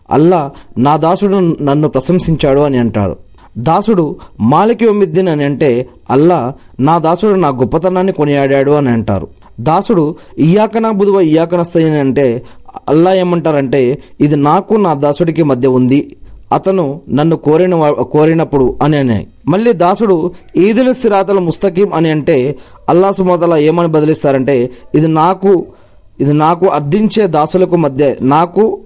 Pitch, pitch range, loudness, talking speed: 155 Hz, 140-185 Hz, -11 LUFS, 115 wpm